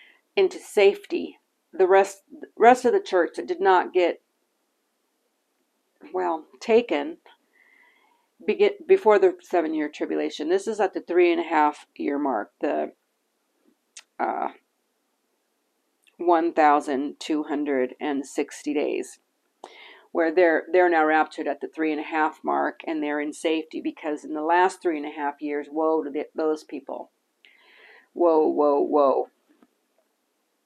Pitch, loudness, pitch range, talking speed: 170 Hz, -23 LUFS, 150-240 Hz, 140 wpm